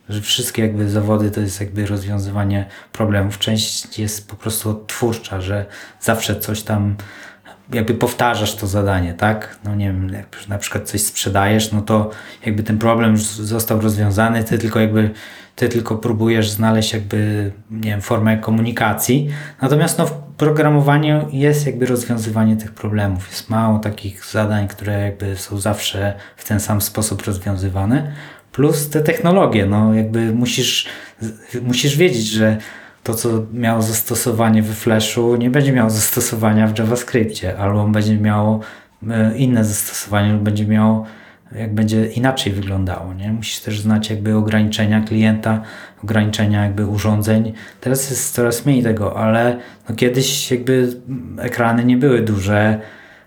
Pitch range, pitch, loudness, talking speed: 105-120 Hz, 110 Hz, -17 LUFS, 145 wpm